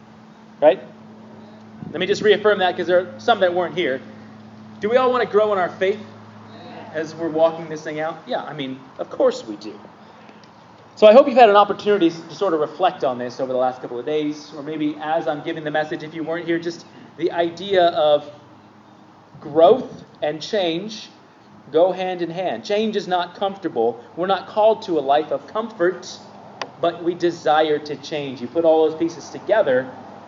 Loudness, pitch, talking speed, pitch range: -20 LUFS, 165 Hz, 195 wpm, 150-190 Hz